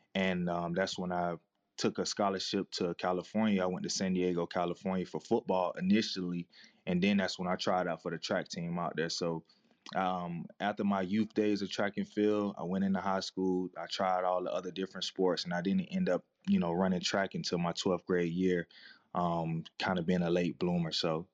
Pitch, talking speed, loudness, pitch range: 90 Hz, 215 wpm, -33 LUFS, 90-100 Hz